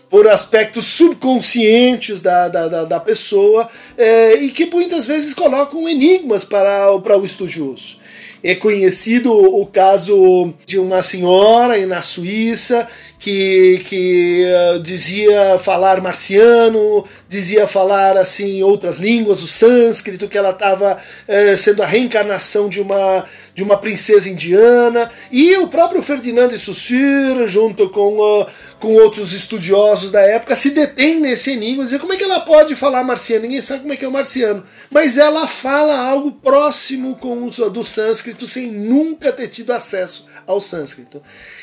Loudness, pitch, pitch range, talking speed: -13 LUFS, 215 Hz, 195-255 Hz, 155 wpm